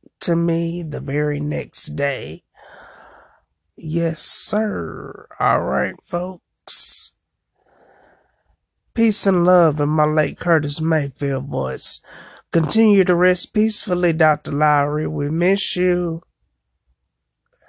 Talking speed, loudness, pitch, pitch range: 100 wpm, -17 LUFS, 165 Hz, 145-180 Hz